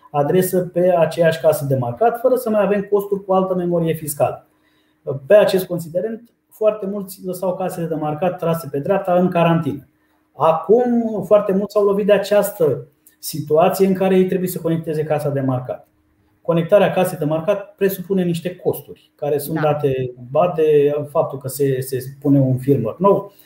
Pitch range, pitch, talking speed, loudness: 150-195 Hz, 175 Hz, 165 wpm, -18 LUFS